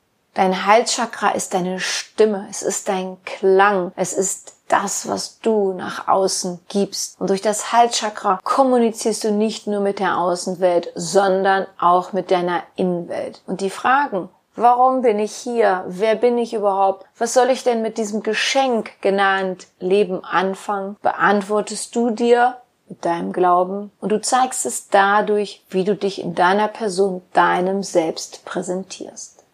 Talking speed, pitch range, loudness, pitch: 150 wpm, 185-220 Hz, -19 LUFS, 200 Hz